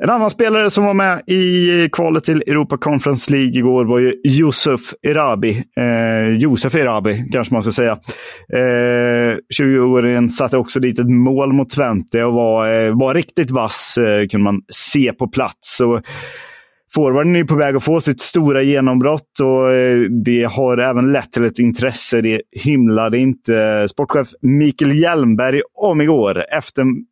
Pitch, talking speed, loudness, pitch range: 130 Hz, 155 wpm, -15 LUFS, 120-145 Hz